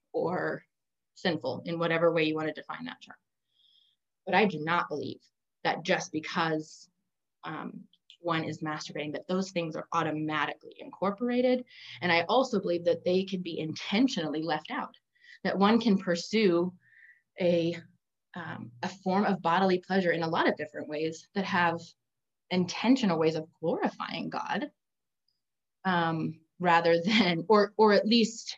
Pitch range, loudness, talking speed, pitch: 155-195 Hz, -29 LUFS, 150 wpm, 170 Hz